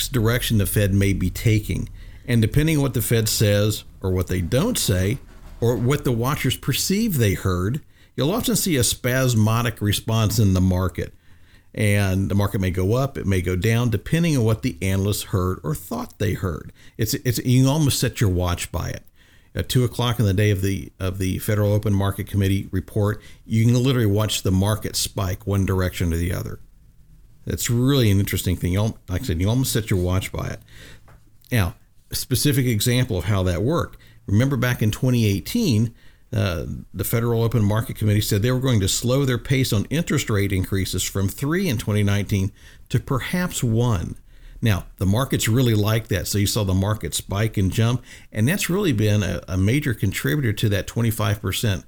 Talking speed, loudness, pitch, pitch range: 195 wpm, -22 LUFS, 110 Hz, 95-120 Hz